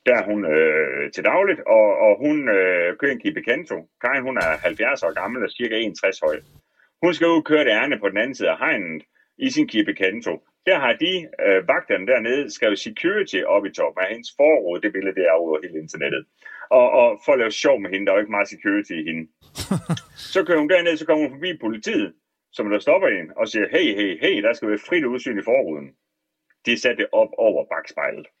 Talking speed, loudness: 230 wpm, -20 LUFS